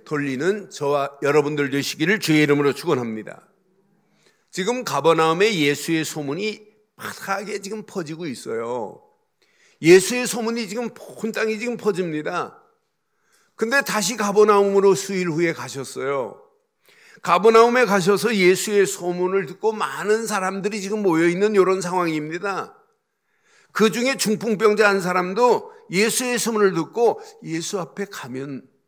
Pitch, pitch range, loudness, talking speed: 205 Hz, 175-235 Hz, -20 LUFS, 300 characters per minute